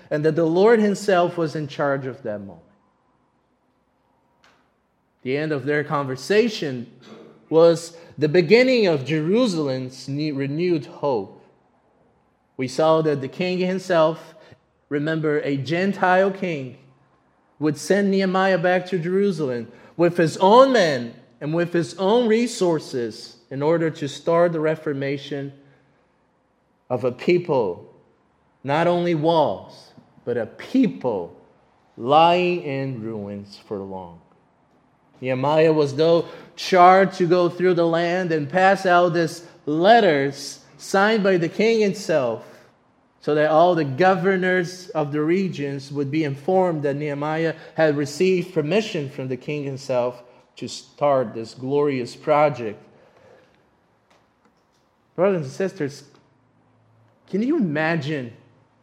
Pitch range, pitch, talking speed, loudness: 140-180 Hz, 155 Hz, 120 wpm, -21 LUFS